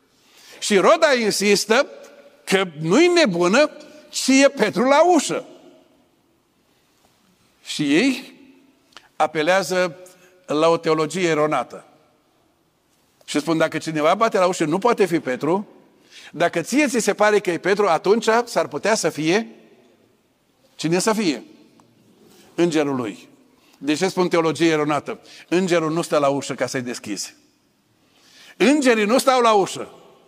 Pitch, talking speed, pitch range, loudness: 190 Hz, 130 wpm, 165-265 Hz, -19 LUFS